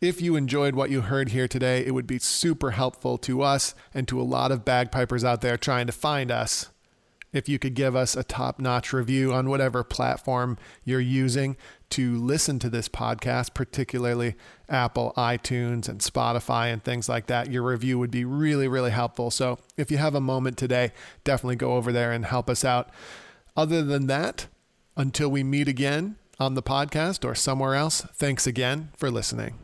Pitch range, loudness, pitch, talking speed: 125-140 Hz, -26 LUFS, 130 Hz, 190 wpm